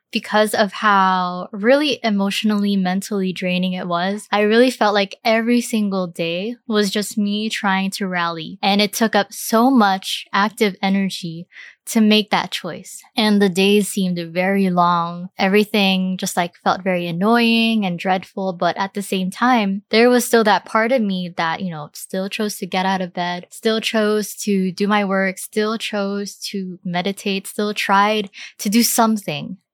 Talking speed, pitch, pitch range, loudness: 170 wpm, 200 Hz, 185-215 Hz, -18 LUFS